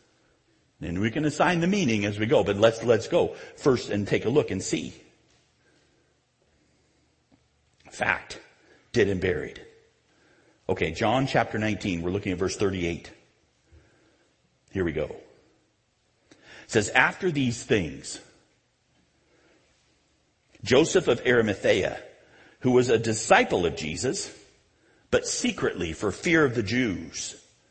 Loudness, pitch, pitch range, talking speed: -25 LUFS, 125 Hz, 110-180 Hz, 125 wpm